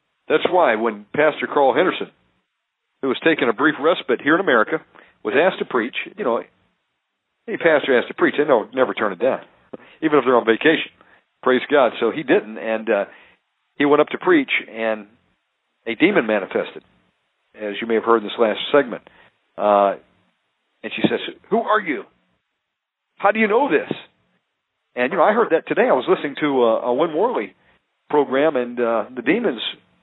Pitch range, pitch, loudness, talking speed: 105-155 Hz, 120 Hz, -19 LUFS, 190 wpm